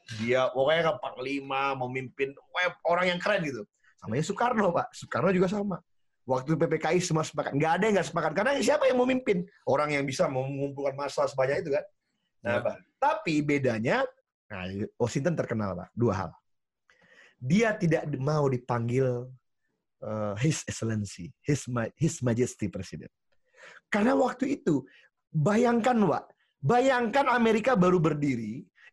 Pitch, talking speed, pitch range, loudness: 150 Hz, 145 wpm, 125-195 Hz, -28 LUFS